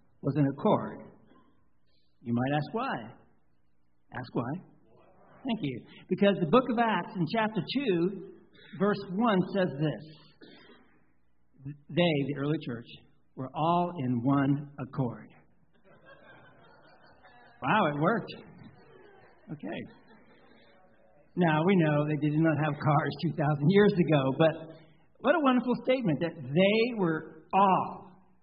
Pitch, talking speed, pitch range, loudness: 160 Hz, 120 wpm, 140-190 Hz, -28 LUFS